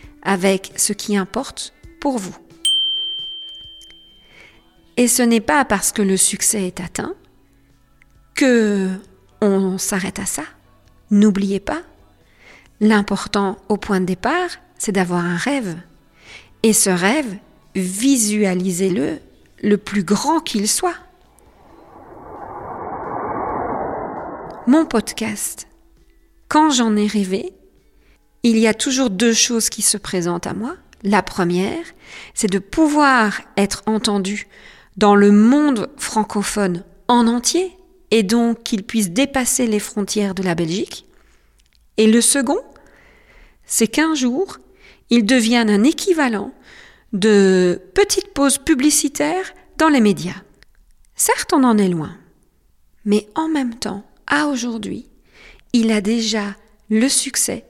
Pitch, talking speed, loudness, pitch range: 220 Hz, 120 wpm, -17 LUFS, 200-275 Hz